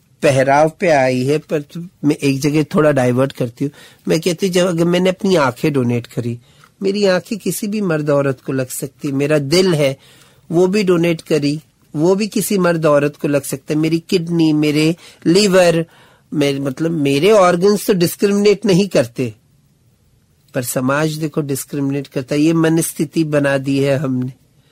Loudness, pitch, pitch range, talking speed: -16 LUFS, 150 Hz, 140-175 Hz, 170 wpm